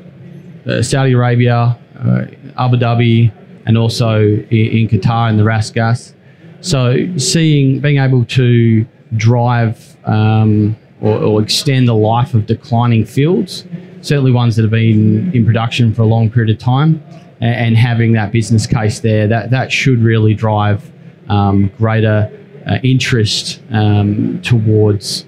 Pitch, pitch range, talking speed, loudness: 115 Hz, 110-135 Hz, 140 wpm, -13 LUFS